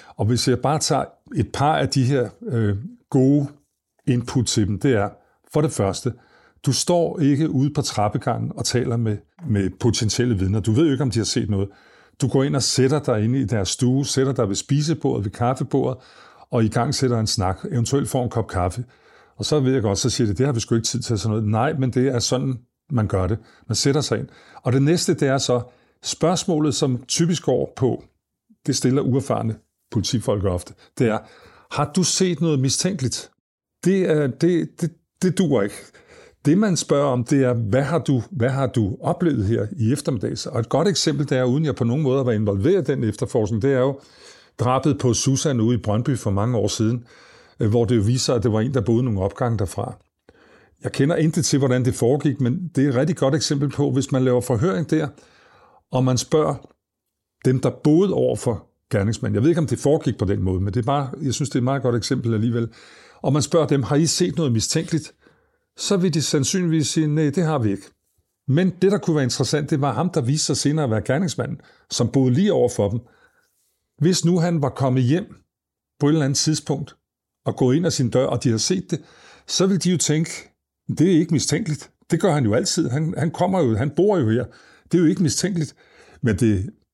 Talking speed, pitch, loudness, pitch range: 225 wpm, 130 Hz, -21 LUFS, 115-150 Hz